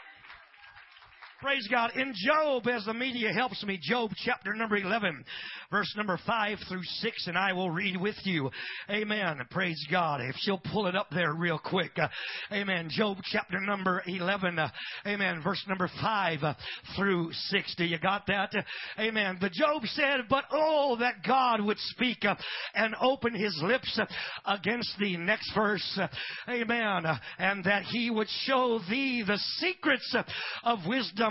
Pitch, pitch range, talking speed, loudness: 205 Hz, 185-235 Hz, 150 wpm, -30 LUFS